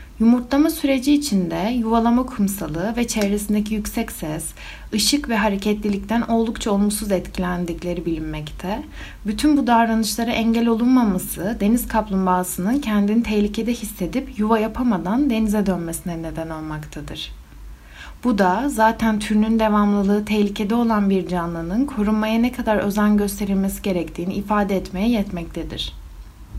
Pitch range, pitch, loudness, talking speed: 185-230 Hz, 210 Hz, -20 LUFS, 115 wpm